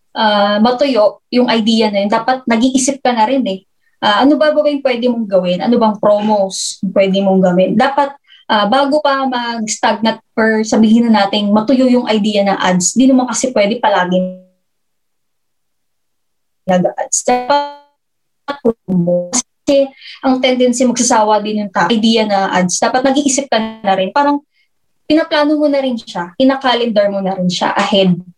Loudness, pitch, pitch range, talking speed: -13 LUFS, 230 Hz, 200-265 Hz, 155 wpm